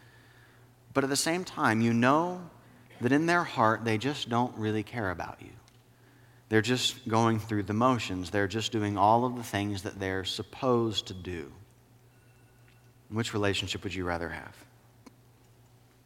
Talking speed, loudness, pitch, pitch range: 160 wpm, -29 LUFS, 120 Hz, 105-125 Hz